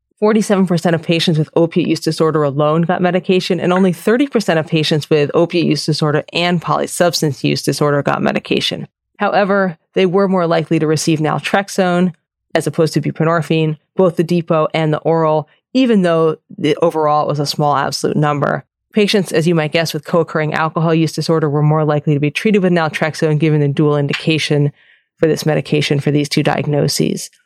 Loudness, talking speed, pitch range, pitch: -15 LUFS, 175 wpm, 150-180 Hz, 160 Hz